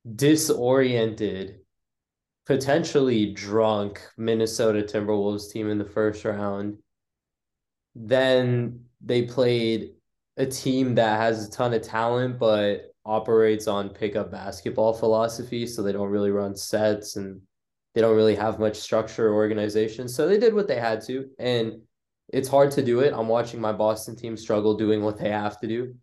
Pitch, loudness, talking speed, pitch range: 110 Hz, -24 LUFS, 155 wpm, 105-120 Hz